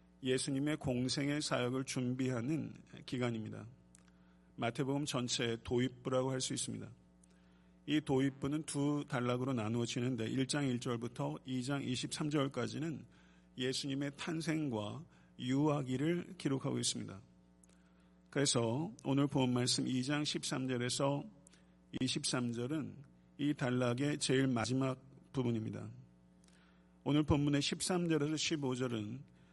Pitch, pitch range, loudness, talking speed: 130 Hz, 110-145 Hz, -37 LUFS, 240 characters per minute